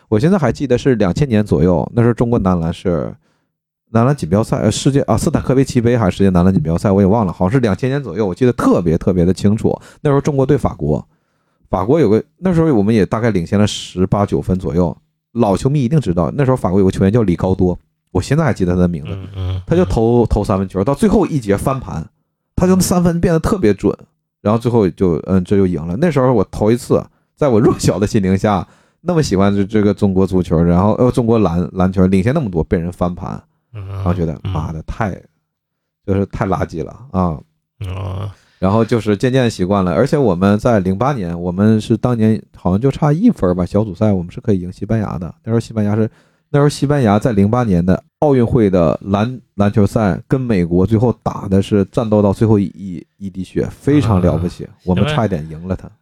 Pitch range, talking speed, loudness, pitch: 95-125 Hz, 335 characters per minute, -15 LUFS, 105 Hz